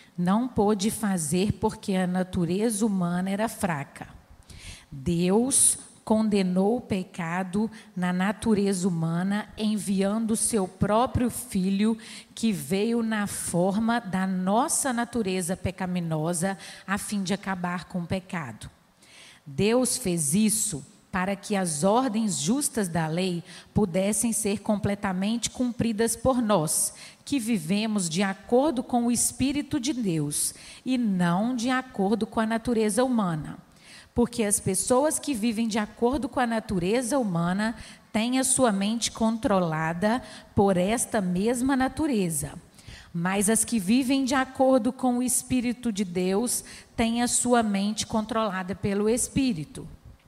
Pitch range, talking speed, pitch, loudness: 185-235 Hz, 130 wpm, 210 Hz, -26 LUFS